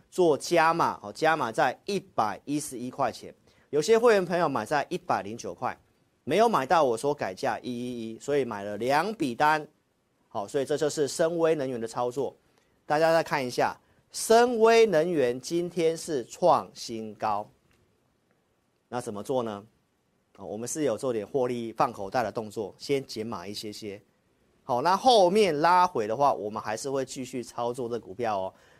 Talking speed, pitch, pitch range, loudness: 250 characters per minute, 135 Hz, 115-165 Hz, -27 LUFS